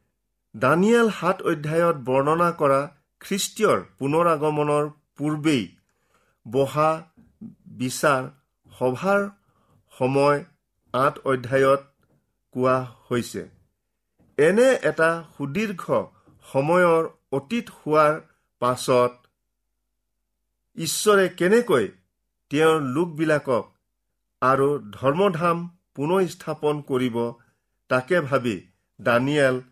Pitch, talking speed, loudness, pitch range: 145 Hz, 70 wpm, -22 LUFS, 130-170 Hz